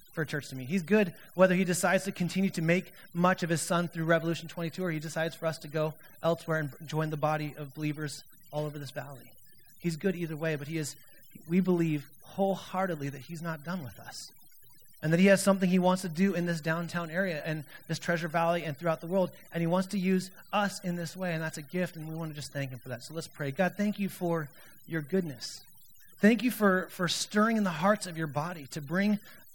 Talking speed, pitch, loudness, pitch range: 245 wpm, 170 Hz, -31 LUFS, 155-185 Hz